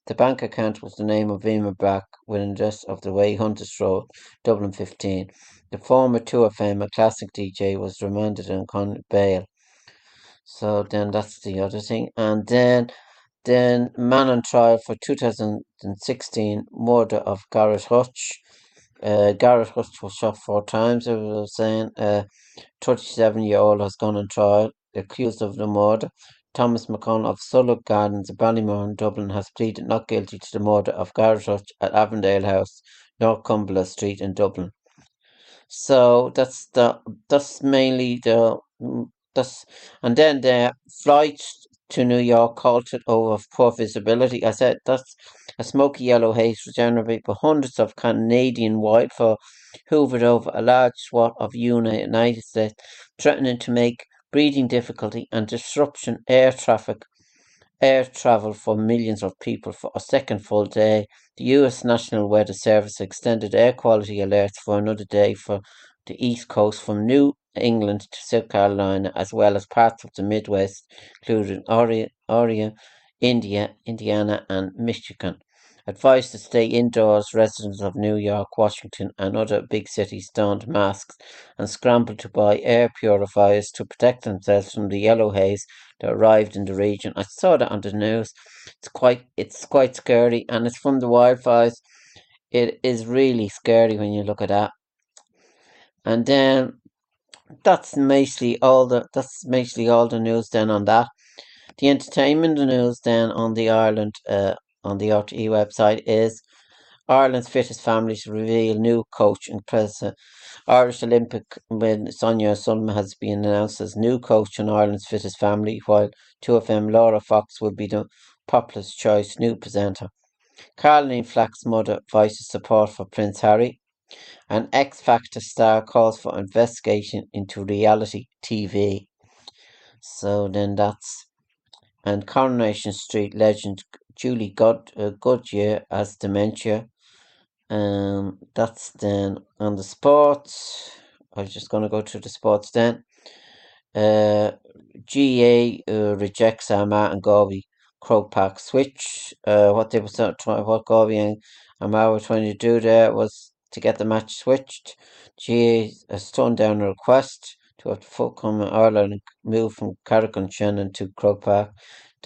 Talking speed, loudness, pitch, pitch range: 150 wpm, -21 LUFS, 110 Hz, 105-120 Hz